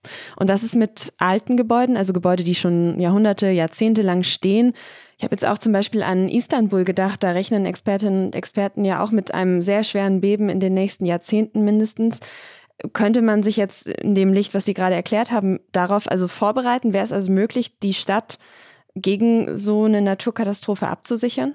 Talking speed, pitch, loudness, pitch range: 185 wpm, 205 Hz, -19 LUFS, 190-220 Hz